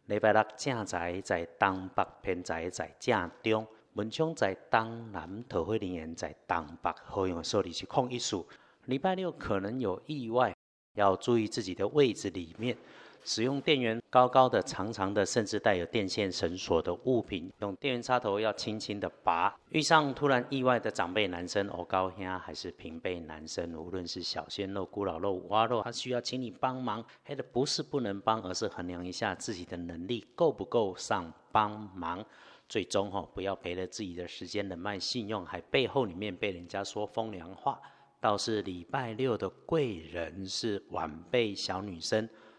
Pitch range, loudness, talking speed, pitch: 90-125 Hz, -32 LUFS, 265 characters per minute, 105 Hz